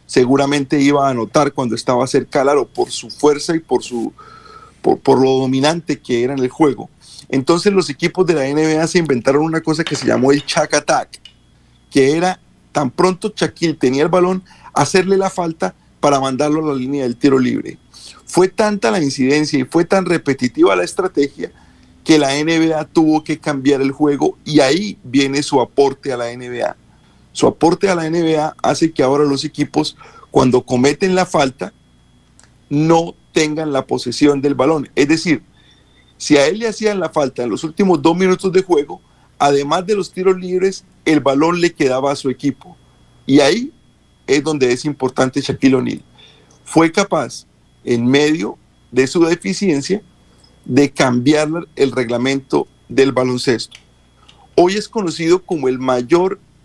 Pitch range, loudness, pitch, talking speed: 130-170 Hz, -16 LUFS, 145 Hz, 170 wpm